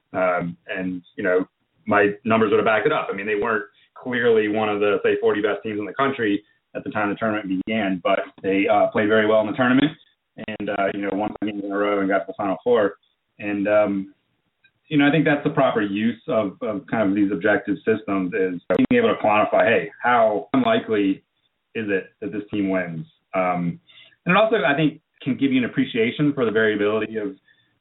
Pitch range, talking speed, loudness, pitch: 100-145 Hz, 220 wpm, -21 LUFS, 105 Hz